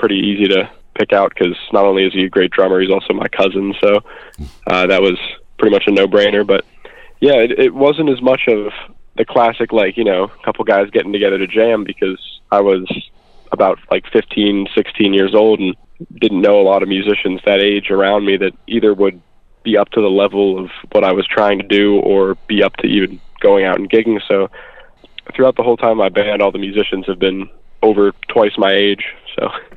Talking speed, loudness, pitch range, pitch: 215 wpm, -14 LUFS, 95-110 Hz, 100 Hz